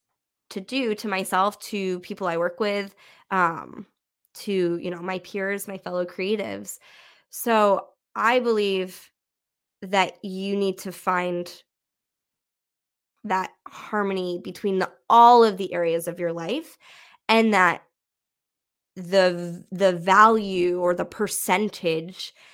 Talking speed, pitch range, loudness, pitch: 120 wpm, 180-205 Hz, -23 LUFS, 190 Hz